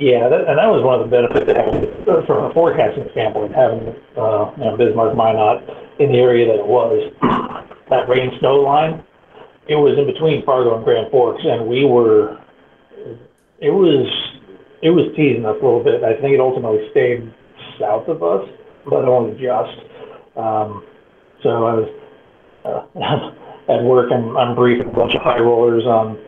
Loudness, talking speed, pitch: -16 LUFS, 175 wpm, 125 Hz